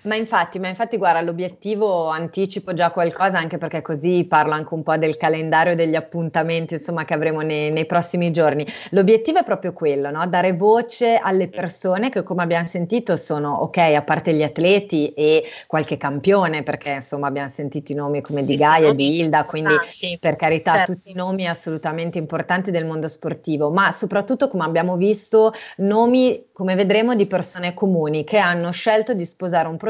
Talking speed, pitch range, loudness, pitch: 180 wpm, 155-190 Hz, -19 LUFS, 170 Hz